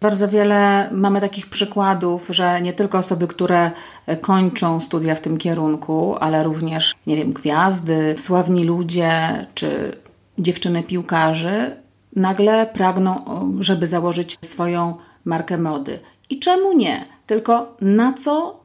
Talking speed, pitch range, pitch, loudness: 120 wpm, 165-200 Hz, 180 Hz, -18 LUFS